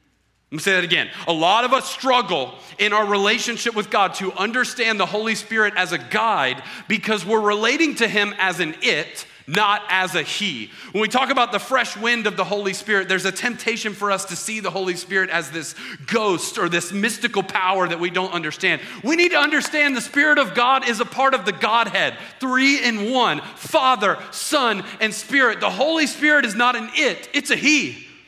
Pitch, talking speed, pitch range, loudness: 215 Hz, 210 wpm, 190-245 Hz, -19 LUFS